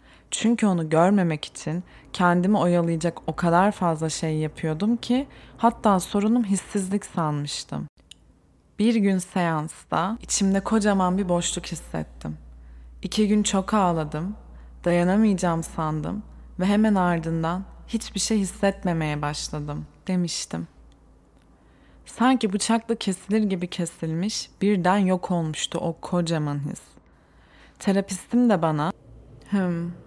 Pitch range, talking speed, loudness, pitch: 160-205 Hz, 105 wpm, -24 LUFS, 180 Hz